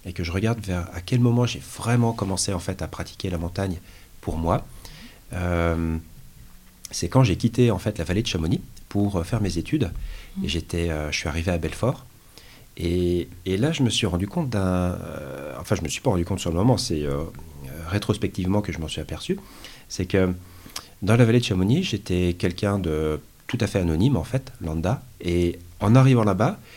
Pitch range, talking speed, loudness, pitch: 85-110 Hz, 205 wpm, -24 LUFS, 95 Hz